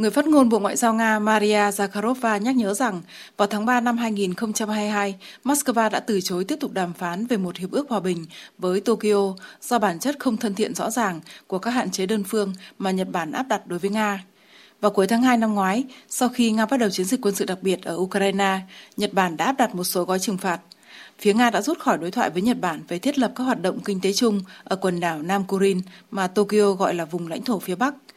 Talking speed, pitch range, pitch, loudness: 250 wpm, 190-235 Hz, 205 Hz, -23 LUFS